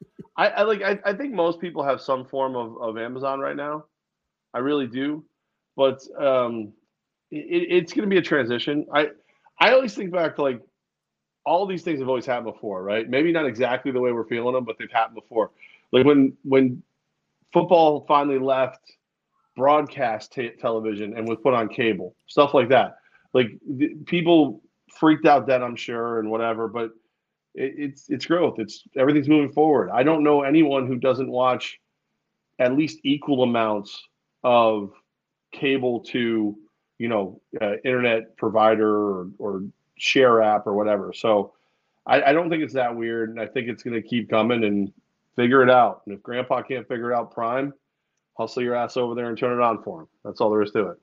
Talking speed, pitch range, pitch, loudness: 185 wpm, 115-145 Hz, 125 Hz, -22 LUFS